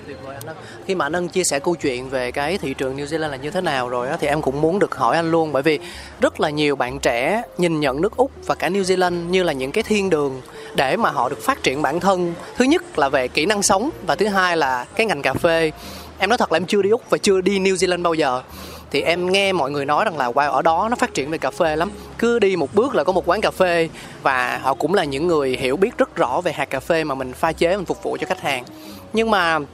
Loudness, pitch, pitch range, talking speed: -20 LUFS, 165 Hz, 140-190 Hz, 280 wpm